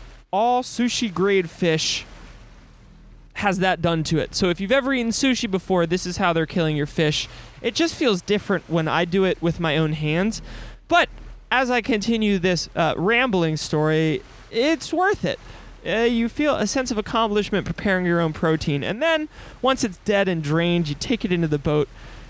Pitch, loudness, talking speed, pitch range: 190 Hz, -22 LUFS, 190 wpm, 165-235 Hz